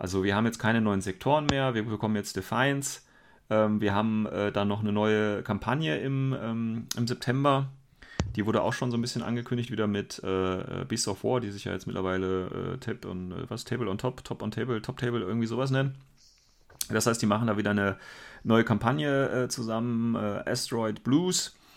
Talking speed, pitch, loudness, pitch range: 185 wpm, 115 Hz, -29 LUFS, 105-125 Hz